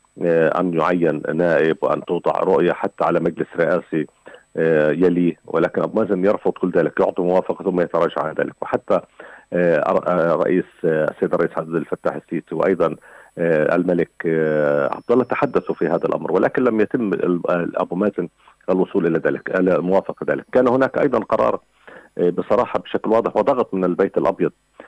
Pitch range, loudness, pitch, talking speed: 80-90 Hz, -19 LUFS, 90 Hz, 140 wpm